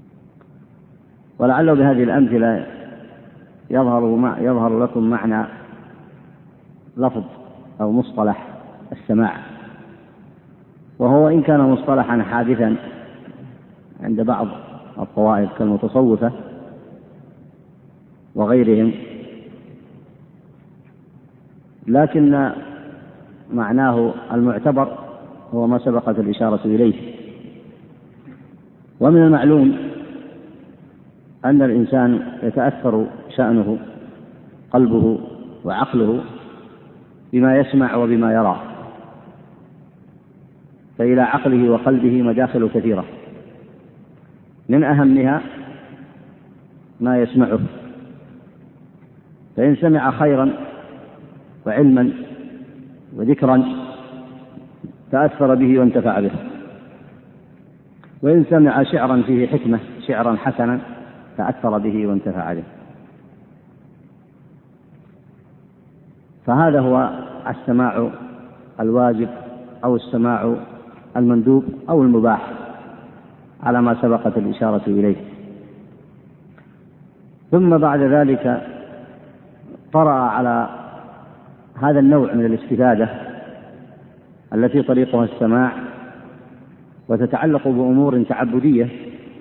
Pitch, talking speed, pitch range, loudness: 125 Hz, 65 wpm, 115-140 Hz, -17 LUFS